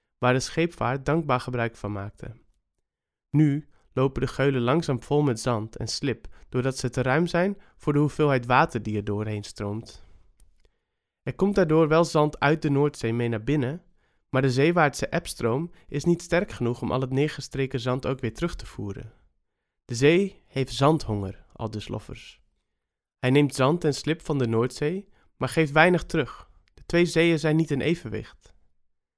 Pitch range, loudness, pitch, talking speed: 115-155 Hz, -25 LUFS, 135 Hz, 175 wpm